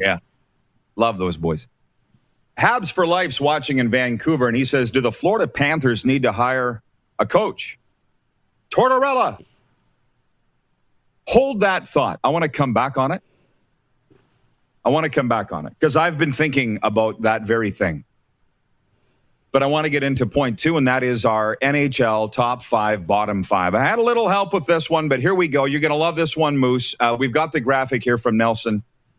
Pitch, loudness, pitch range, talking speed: 130 Hz, -19 LUFS, 115-155 Hz, 190 wpm